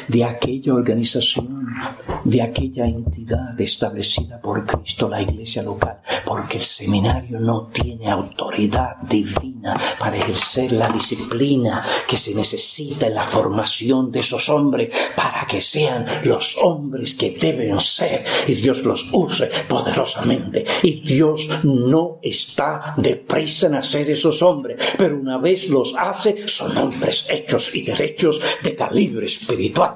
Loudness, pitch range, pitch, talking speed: -19 LUFS, 115-150 Hz, 130 Hz, 135 wpm